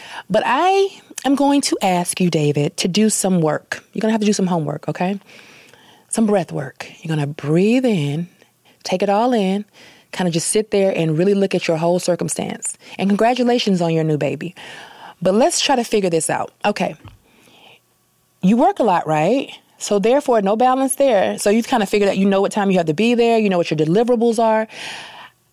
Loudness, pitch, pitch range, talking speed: -18 LUFS, 200 Hz, 170-230 Hz, 210 wpm